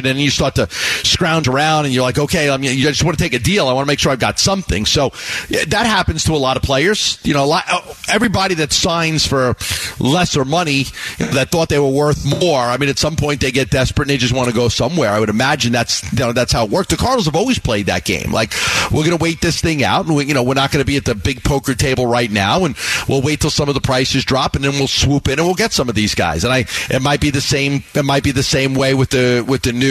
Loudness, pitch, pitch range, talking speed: -15 LUFS, 135 Hz, 125-150 Hz, 295 wpm